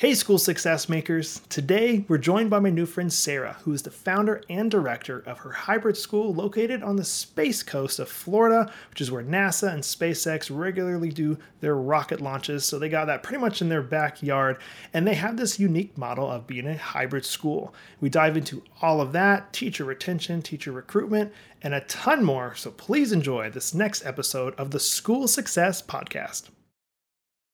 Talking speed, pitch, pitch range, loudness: 185 wpm, 165 Hz, 145-200 Hz, -25 LUFS